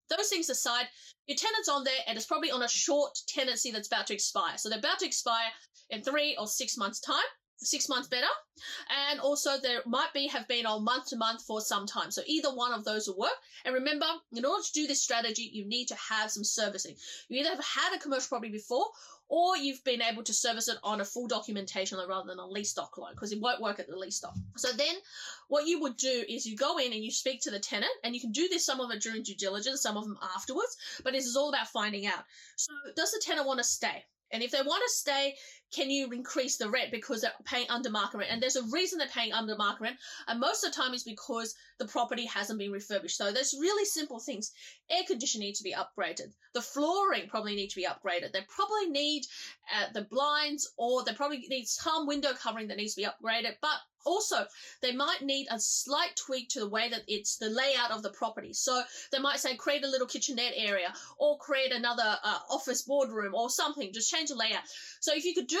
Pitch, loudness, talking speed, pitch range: 255 Hz, -32 LUFS, 240 wpm, 220-290 Hz